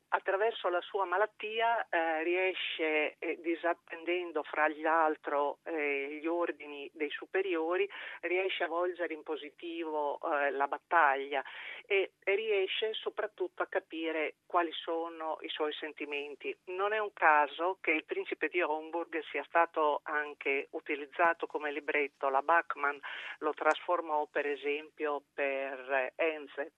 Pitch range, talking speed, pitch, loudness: 150-180 Hz, 130 wpm, 160 Hz, -33 LUFS